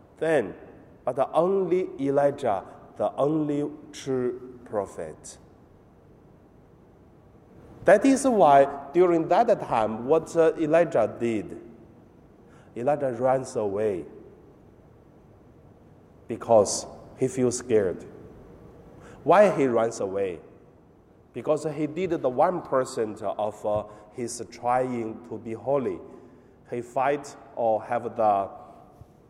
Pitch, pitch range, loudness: 135 Hz, 120-160 Hz, -25 LUFS